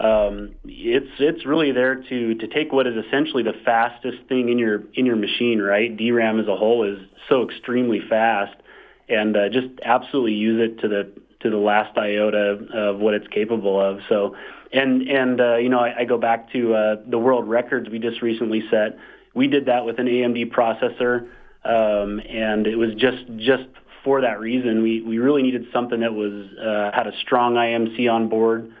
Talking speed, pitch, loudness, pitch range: 195 wpm, 115 Hz, -21 LUFS, 105-125 Hz